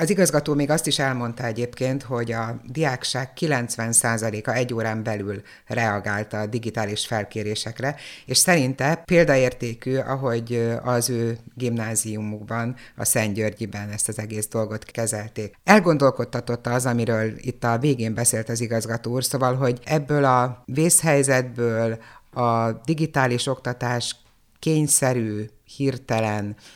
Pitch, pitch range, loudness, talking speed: 120 Hz, 110-130 Hz, -23 LUFS, 115 wpm